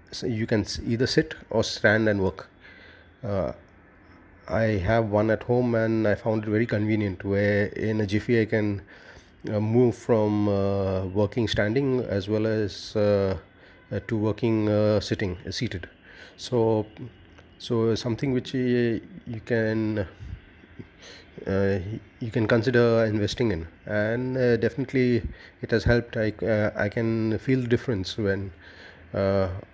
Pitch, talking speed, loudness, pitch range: 105 Hz, 145 wpm, -25 LUFS, 95-115 Hz